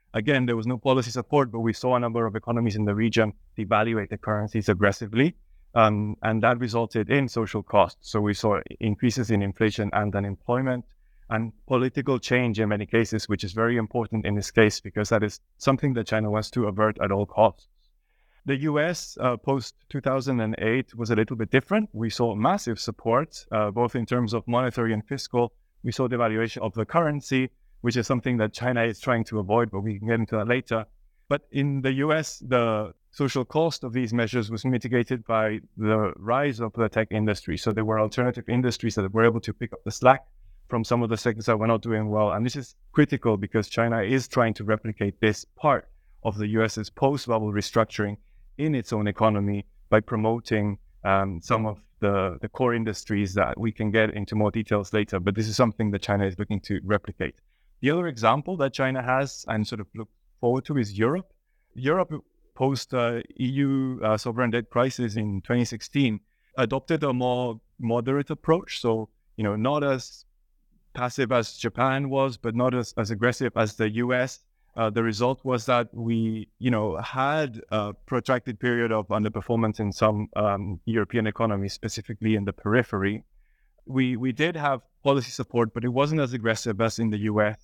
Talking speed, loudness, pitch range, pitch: 190 wpm, -26 LUFS, 105-125 Hz, 115 Hz